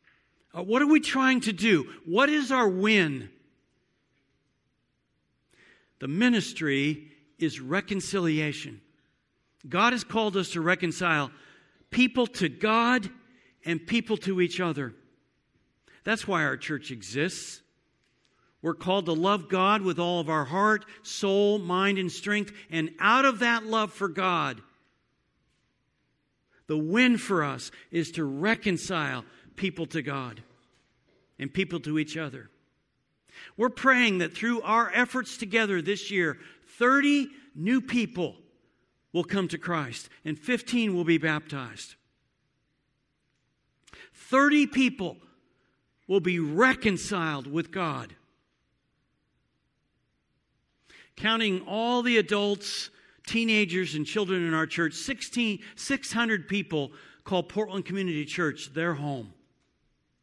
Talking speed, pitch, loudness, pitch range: 115 wpm, 185 Hz, -27 LUFS, 160-225 Hz